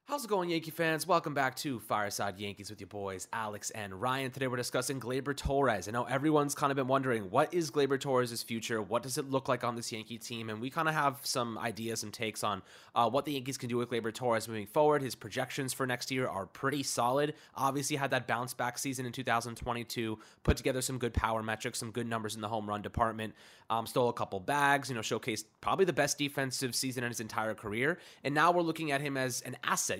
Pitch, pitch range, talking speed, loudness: 125 Hz, 115-140 Hz, 245 wpm, -33 LUFS